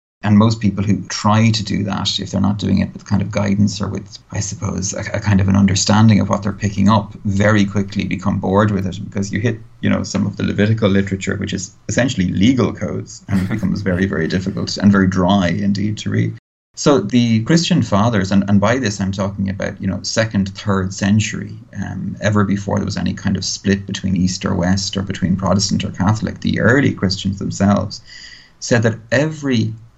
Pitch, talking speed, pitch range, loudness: 100 Hz, 215 wpm, 95-105 Hz, -17 LUFS